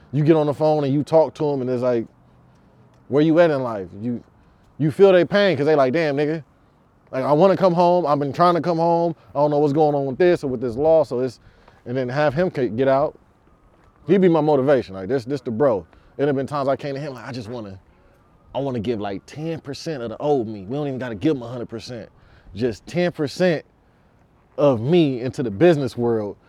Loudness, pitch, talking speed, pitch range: -20 LUFS, 140 Hz, 245 wpm, 120-155 Hz